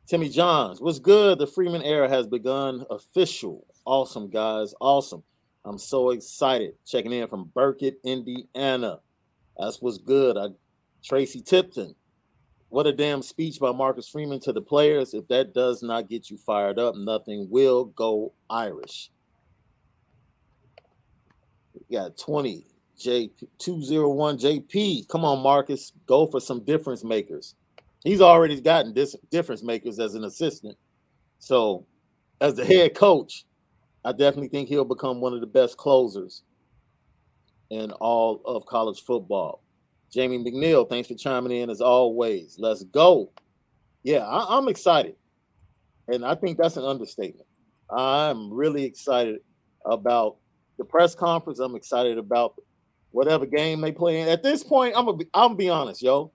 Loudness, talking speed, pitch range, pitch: -23 LUFS, 145 wpm, 120-155 Hz, 135 Hz